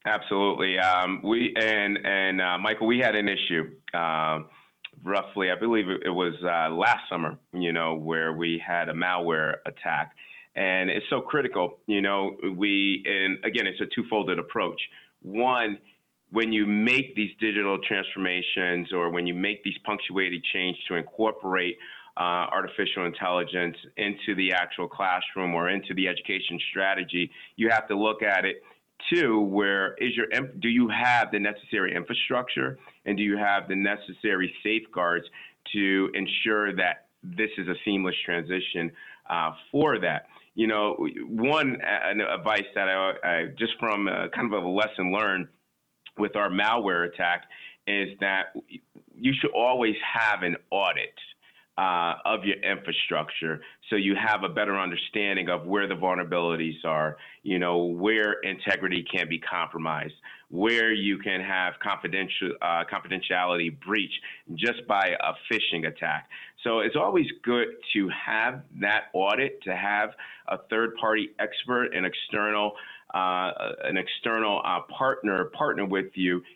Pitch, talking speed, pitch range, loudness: 95 Hz, 150 wpm, 90-105 Hz, -26 LUFS